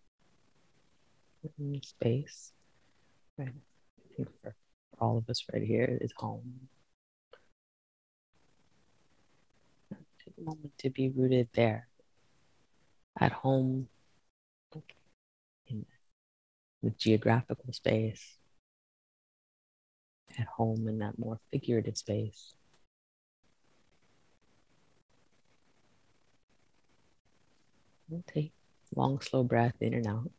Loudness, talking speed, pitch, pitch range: -33 LUFS, 85 wpm, 115 Hz, 105-130 Hz